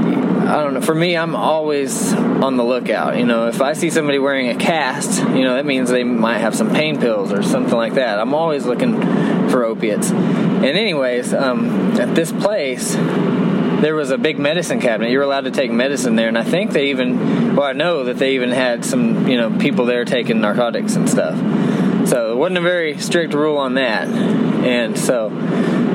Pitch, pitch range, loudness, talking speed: 165 Hz, 135-215 Hz, -16 LUFS, 205 wpm